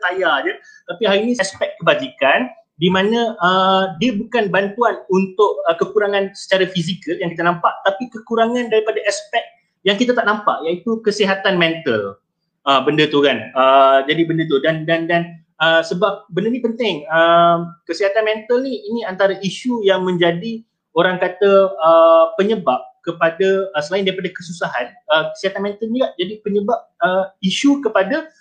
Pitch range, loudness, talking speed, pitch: 170-225 Hz, -17 LUFS, 160 wpm, 195 Hz